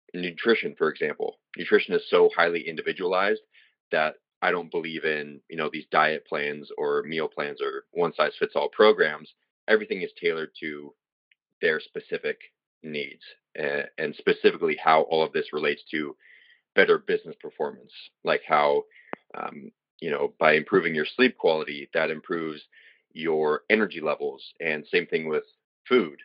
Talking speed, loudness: 150 wpm, -26 LUFS